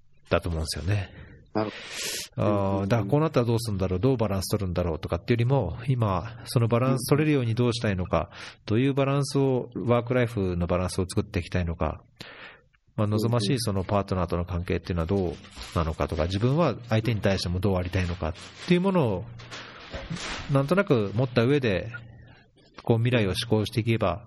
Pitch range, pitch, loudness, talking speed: 90-120 Hz, 105 Hz, -26 LUFS, 440 characters per minute